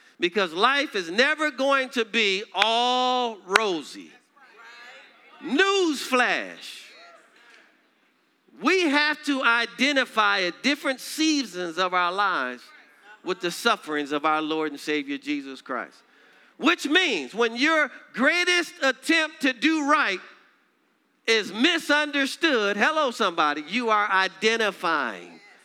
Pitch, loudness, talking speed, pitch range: 250 Hz, -23 LUFS, 110 wpm, 195-300 Hz